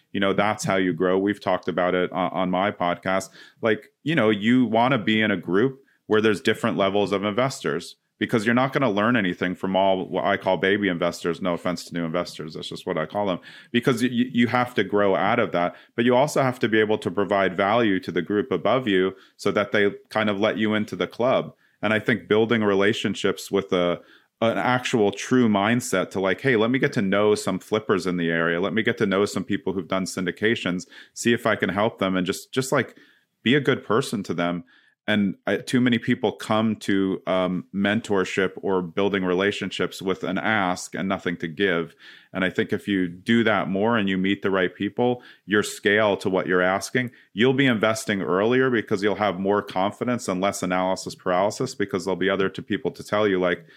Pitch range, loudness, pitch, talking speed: 95-110 Hz, -23 LUFS, 100 Hz, 225 wpm